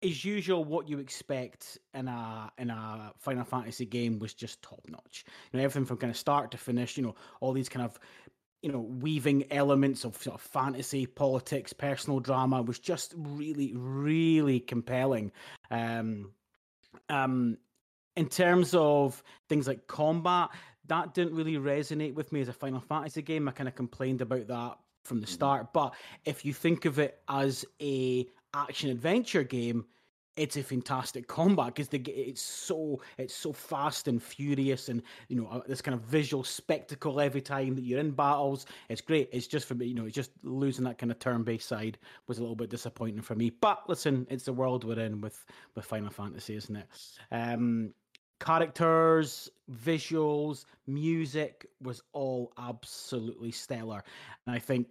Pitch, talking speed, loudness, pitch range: 130 Hz, 175 wpm, -32 LUFS, 120-150 Hz